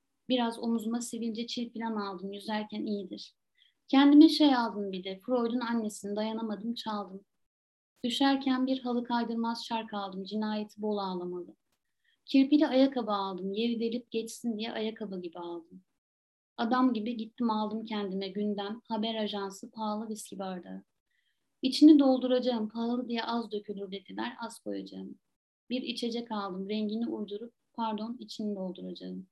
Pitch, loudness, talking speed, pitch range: 225 Hz, -31 LUFS, 130 wpm, 200-240 Hz